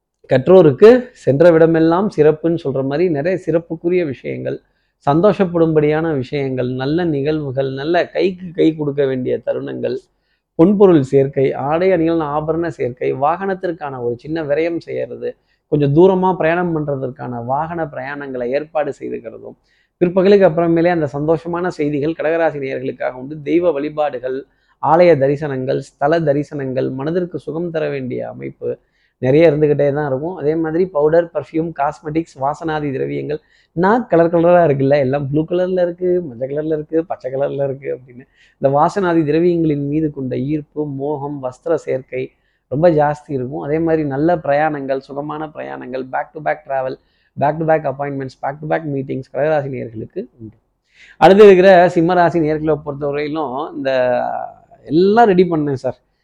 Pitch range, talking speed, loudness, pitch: 140-170 Hz, 135 wpm, -16 LUFS, 155 Hz